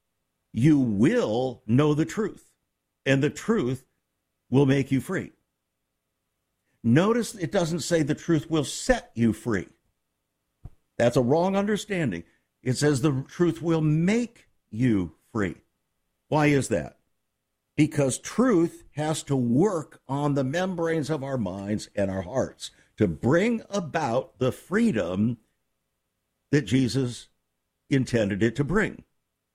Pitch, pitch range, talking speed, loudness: 140 Hz, 115-165 Hz, 125 wpm, -25 LUFS